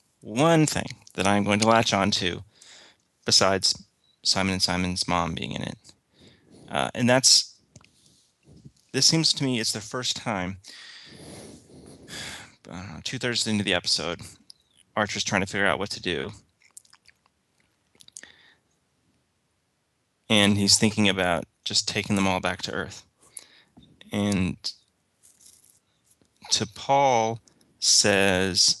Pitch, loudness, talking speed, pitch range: 100 Hz, -23 LUFS, 115 wpm, 95-115 Hz